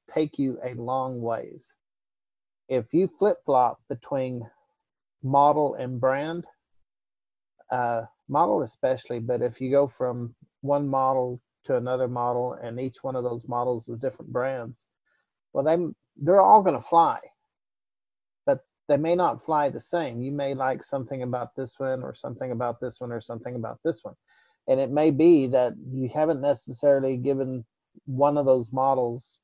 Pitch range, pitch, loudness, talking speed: 125-145 Hz, 130 Hz, -25 LUFS, 160 wpm